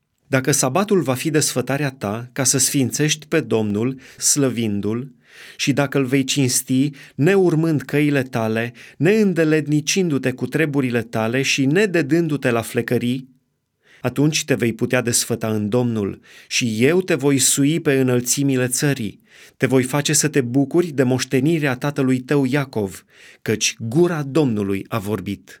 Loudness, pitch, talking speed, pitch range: -19 LUFS, 135 Hz, 140 wpm, 120-145 Hz